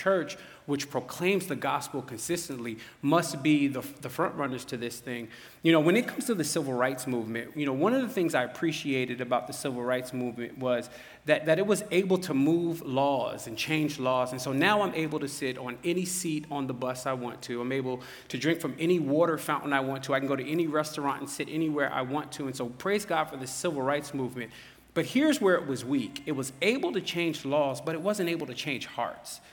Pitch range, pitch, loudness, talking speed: 130-165 Hz, 145 Hz, -29 LUFS, 240 wpm